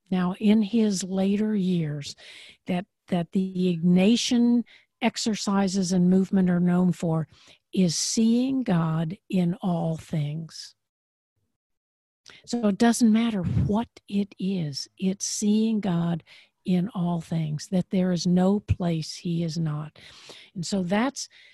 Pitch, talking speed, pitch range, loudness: 185 Hz, 125 wpm, 170-210 Hz, -25 LUFS